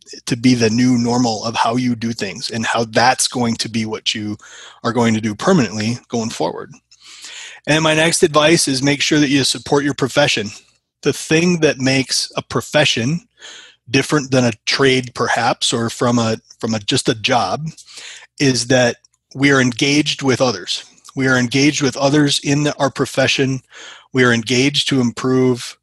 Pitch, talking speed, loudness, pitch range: 130 Hz, 180 wpm, -16 LUFS, 120-145 Hz